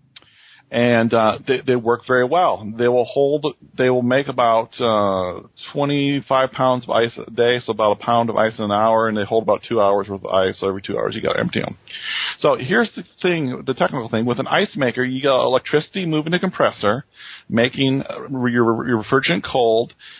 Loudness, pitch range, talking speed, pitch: -19 LUFS, 115-135 Hz, 205 wpm, 125 Hz